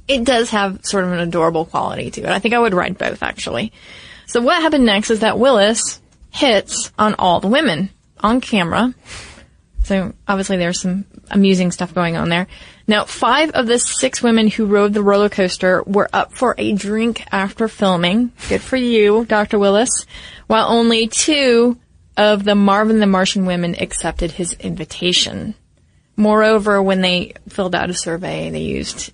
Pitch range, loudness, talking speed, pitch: 185-230 Hz, -16 LUFS, 175 wpm, 205 Hz